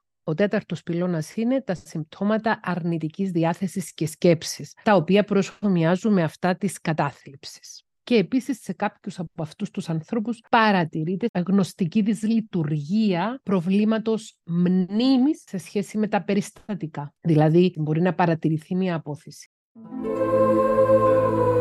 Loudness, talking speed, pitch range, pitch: -23 LUFS, 115 wpm, 170-215 Hz, 190 Hz